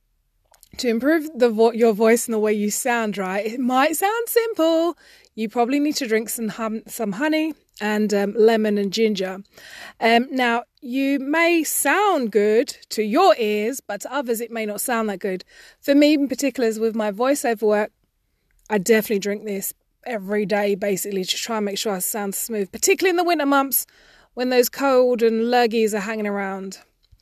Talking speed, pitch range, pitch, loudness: 185 wpm, 210-275 Hz, 230 Hz, -21 LUFS